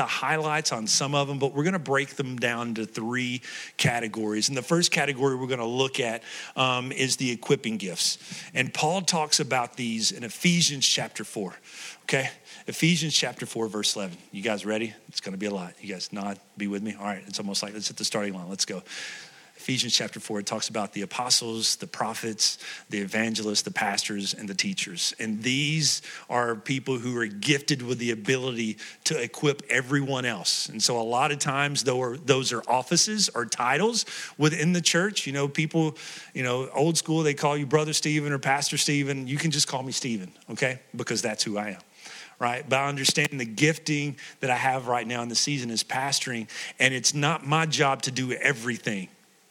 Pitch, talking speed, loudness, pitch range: 130 Hz, 205 wpm, -26 LUFS, 115-150 Hz